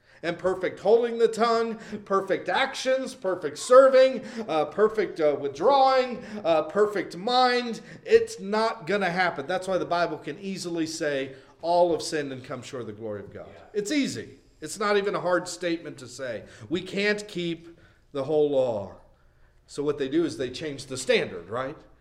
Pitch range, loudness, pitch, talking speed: 150-225 Hz, -25 LUFS, 175 Hz, 175 wpm